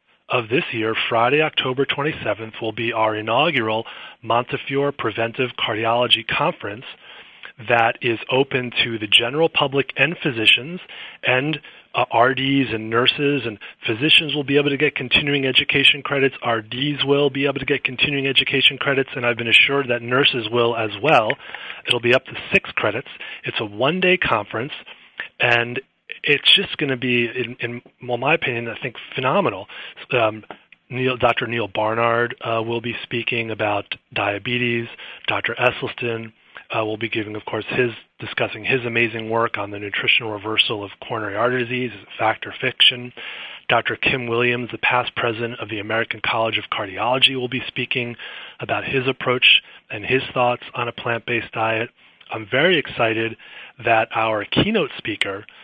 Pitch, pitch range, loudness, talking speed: 120 Hz, 115-135 Hz, -19 LUFS, 160 wpm